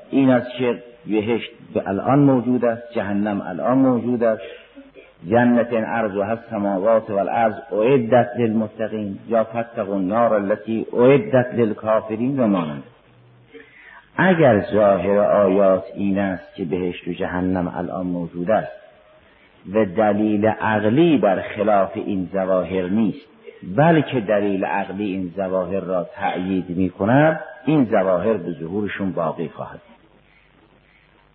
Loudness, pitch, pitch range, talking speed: -20 LUFS, 105 Hz, 95-115 Hz, 125 wpm